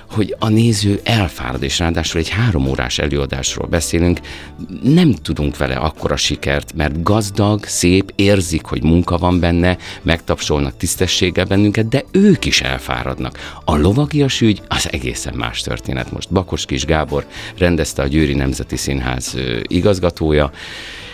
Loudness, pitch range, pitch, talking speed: -16 LUFS, 75-100 Hz, 85 Hz, 135 wpm